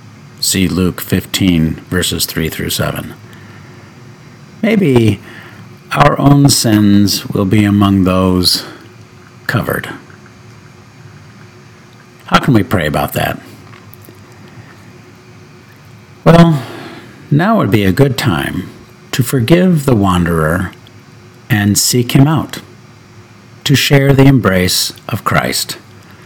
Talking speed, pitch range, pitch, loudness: 100 wpm, 100-130 Hz, 120 Hz, -12 LUFS